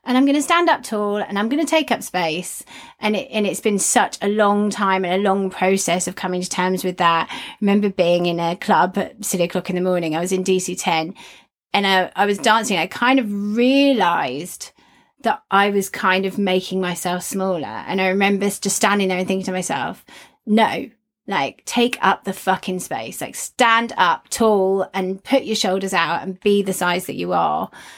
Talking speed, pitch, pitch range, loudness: 210 wpm, 195 Hz, 185-215 Hz, -19 LUFS